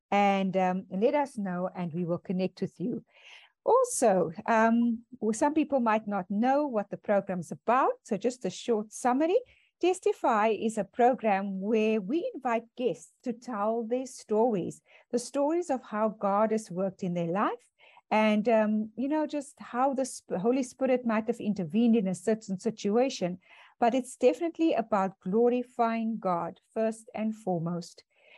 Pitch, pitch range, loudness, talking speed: 225 Hz, 200-250 Hz, -29 LUFS, 165 wpm